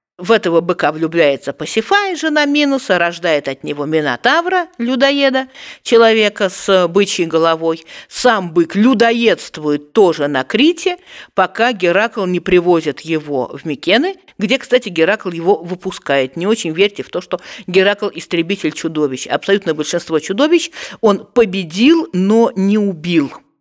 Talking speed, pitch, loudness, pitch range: 130 wpm, 190 Hz, -15 LUFS, 165-235 Hz